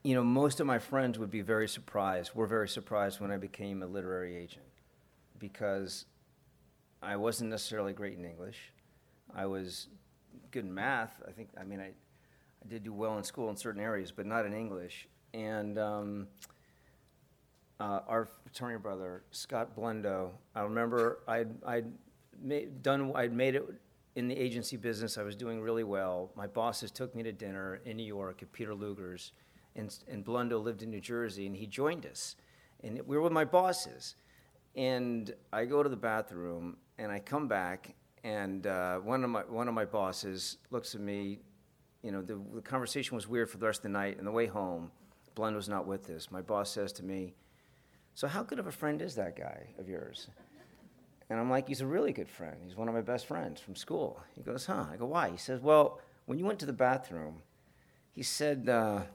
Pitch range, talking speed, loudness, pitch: 100-125 Hz, 200 wpm, -36 LUFS, 110 Hz